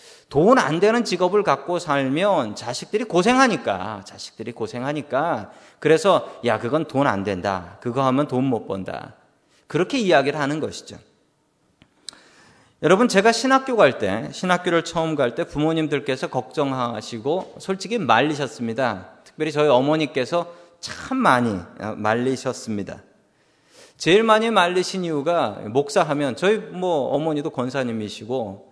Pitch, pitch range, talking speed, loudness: 145 Hz, 125-180 Hz, 300 characters per minute, -21 LUFS